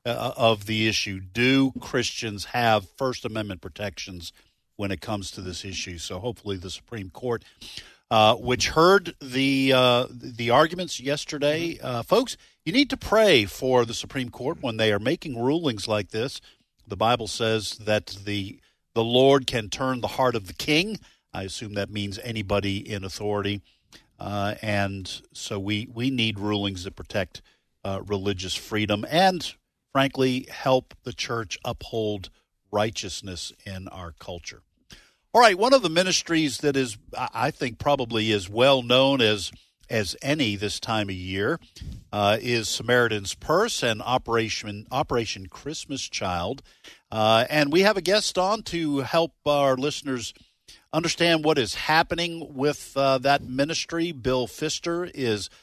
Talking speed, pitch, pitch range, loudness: 150 wpm, 115 Hz, 100-140 Hz, -24 LUFS